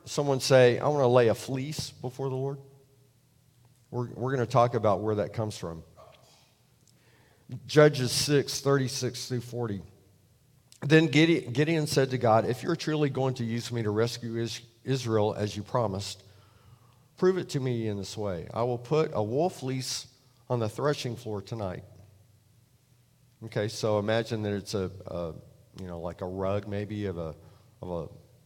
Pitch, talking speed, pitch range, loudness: 120 Hz, 165 wpm, 105-135 Hz, -28 LUFS